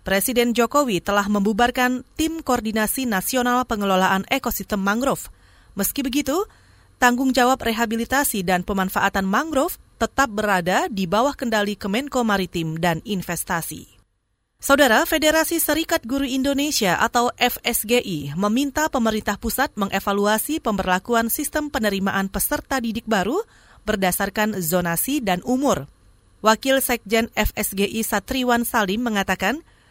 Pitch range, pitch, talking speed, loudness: 195-265 Hz, 225 Hz, 110 wpm, -21 LUFS